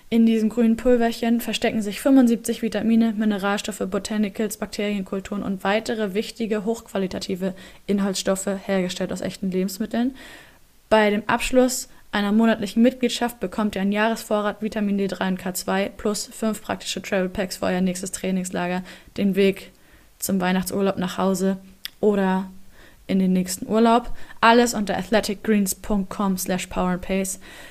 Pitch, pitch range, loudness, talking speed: 210 Hz, 190-225 Hz, -23 LUFS, 125 wpm